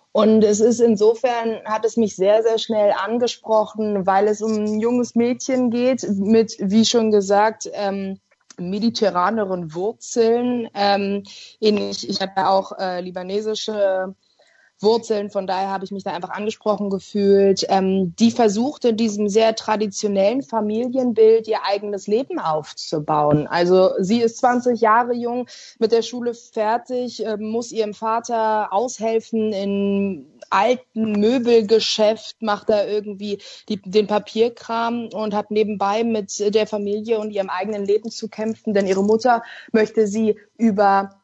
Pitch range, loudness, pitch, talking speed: 200-230 Hz, -20 LUFS, 215 Hz, 135 wpm